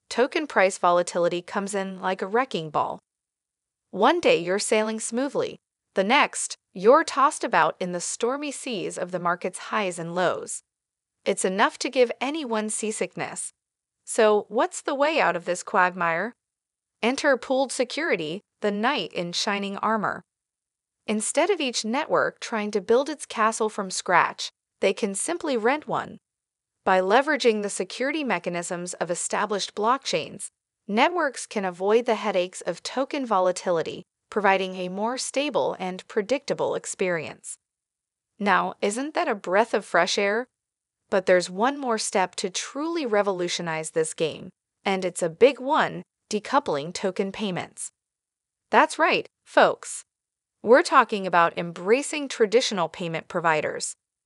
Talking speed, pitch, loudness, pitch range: 140 wpm, 220 Hz, -24 LUFS, 185-270 Hz